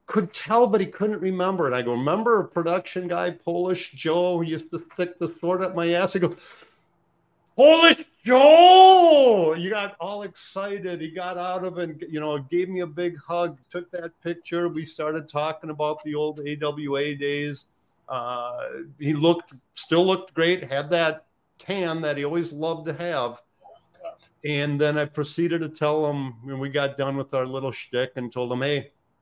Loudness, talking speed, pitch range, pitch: -22 LUFS, 185 wpm, 150-180 Hz, 170 Hz